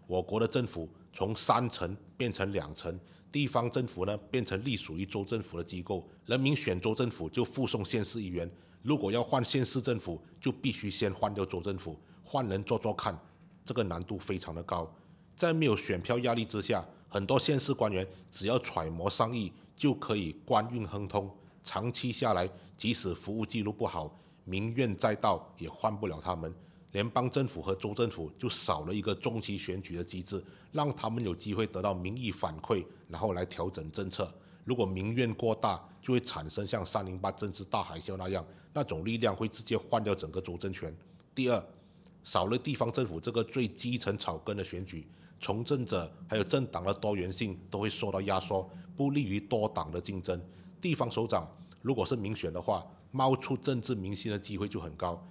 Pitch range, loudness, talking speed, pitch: 95-120 Hz, -34 LUFS, 285 characters per minute, 105 Hz